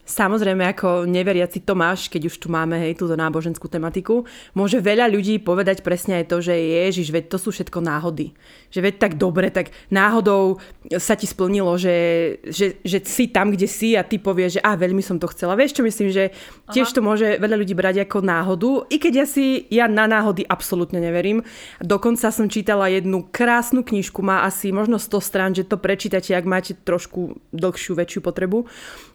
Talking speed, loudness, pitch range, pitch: 190 wpm, -20 LUFS, 180-215 Hz, 190 Hz